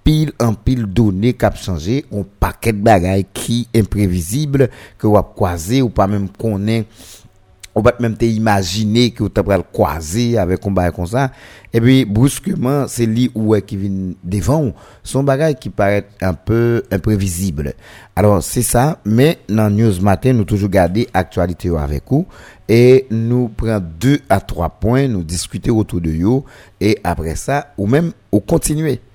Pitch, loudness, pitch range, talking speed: 110 Hz, -16 LUFS, 95-125 Hz, 165 wpm